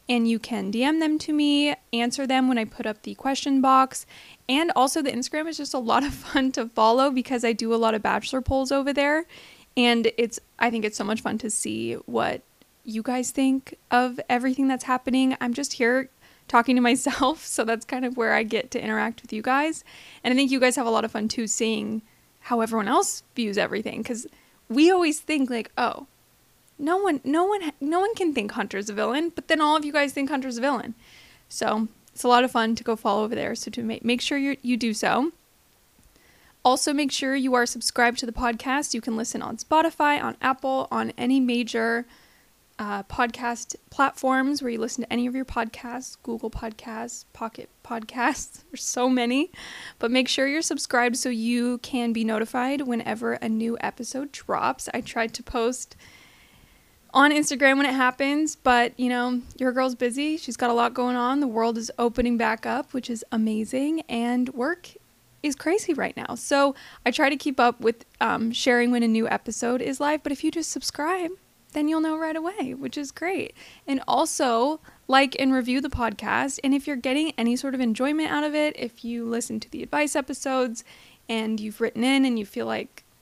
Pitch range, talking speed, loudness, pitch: 235-280 Hz, 205 wpm, -24 LUFS, 255 Hz